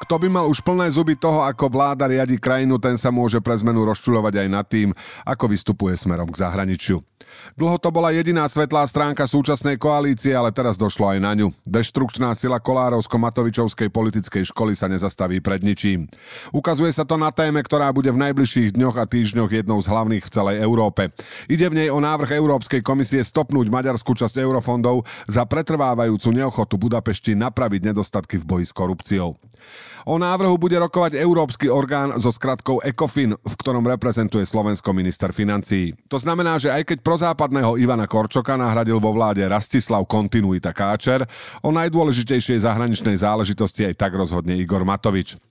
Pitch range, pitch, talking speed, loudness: 105-140 Hz, 120 Hz, 165 wpm, -20 LUFS